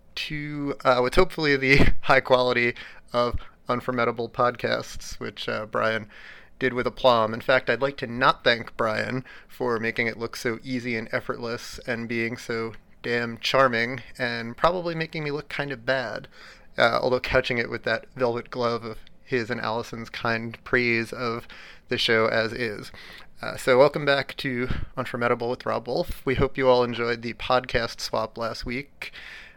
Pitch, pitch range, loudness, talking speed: 125 Hz, 115-130 Hz, -25 LUFS, 170 wpm